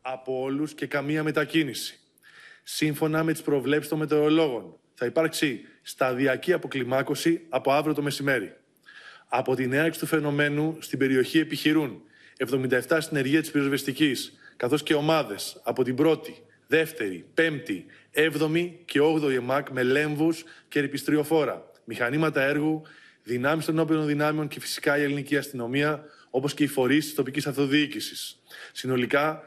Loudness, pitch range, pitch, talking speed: -26 LUFS, 135-155 Hz, 150 Hz, 135 wpm